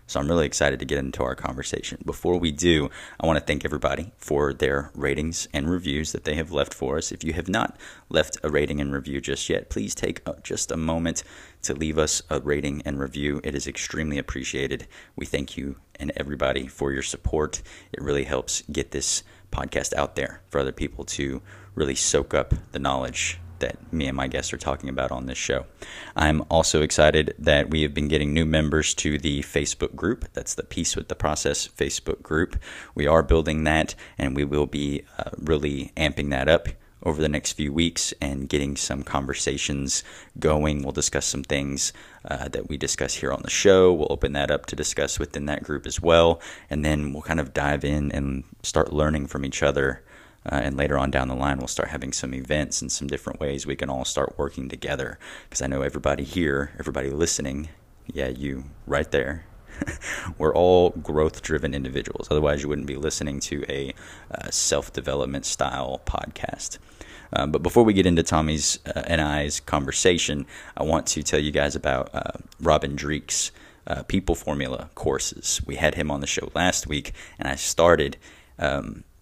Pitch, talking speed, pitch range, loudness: 75 Hz, 195 wpm, 70-80 Hz, -25 LUFS